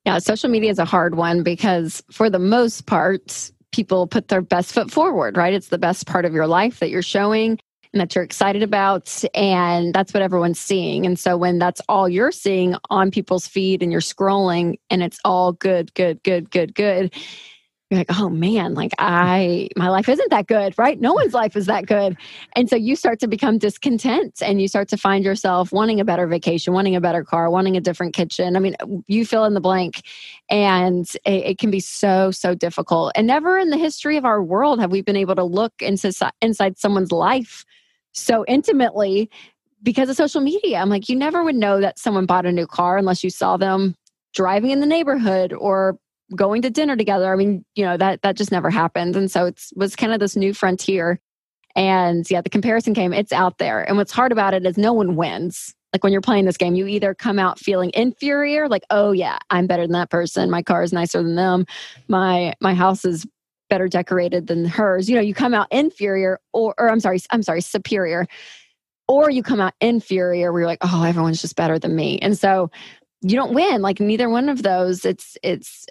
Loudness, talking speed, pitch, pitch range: -19 LUFS, 215 wpm, 195 Hz, 180-220 Hz